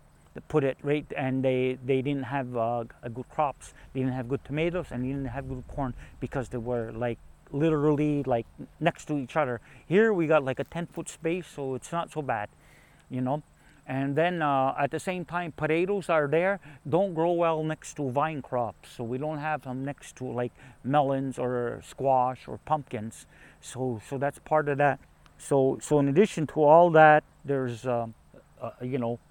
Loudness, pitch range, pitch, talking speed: -28 LUFS, 125-155 Hz, 140 Hz, 200 wpm